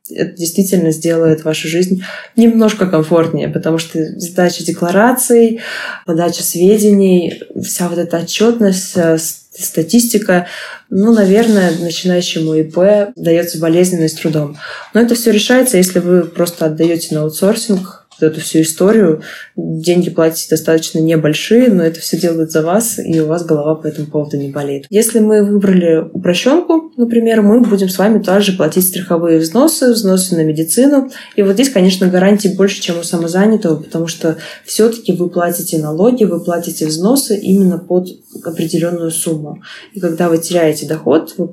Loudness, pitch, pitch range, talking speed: -12 LUFS, 175 Hz, 165-205 Hz, 150 wpm